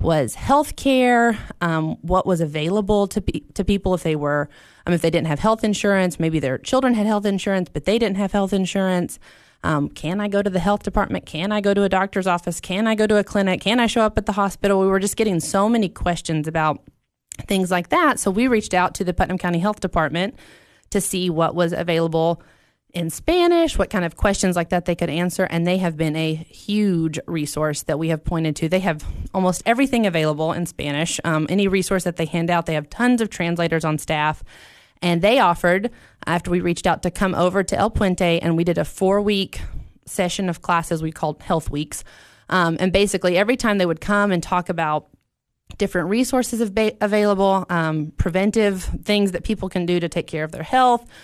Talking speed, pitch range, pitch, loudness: 215 wpm, 165-205 Hz, 185 Hz, -20 LUFS